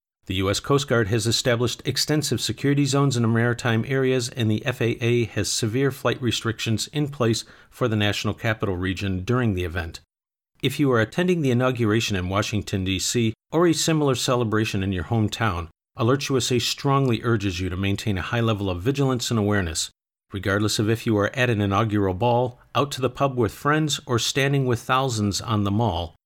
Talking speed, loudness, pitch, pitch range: 185 wpm, -23 LUFS, 115 Hz, 105-130 Hz